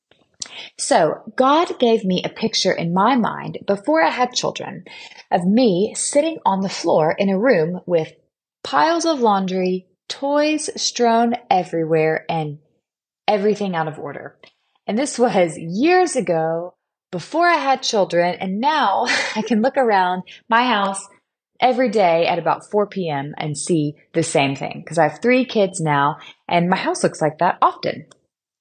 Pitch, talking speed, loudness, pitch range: 195 Hz, 155 wpm, -19 LUFS, 170-245 Hz